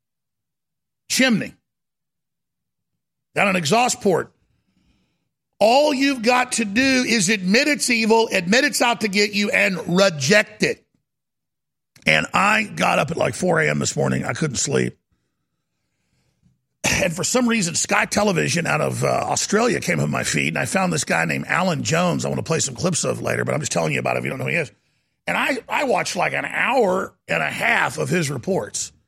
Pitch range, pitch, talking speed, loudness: 195-245 Hz, 220 Hz, 190 wpm, -19 LUFS